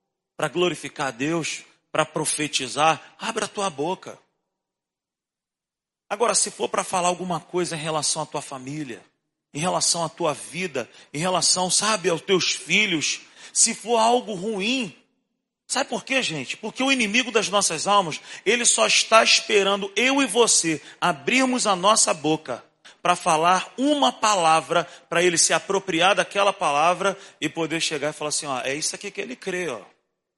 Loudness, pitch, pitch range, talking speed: -21 LUFS, 180 Hz, 160-210 Hz, 160 wpm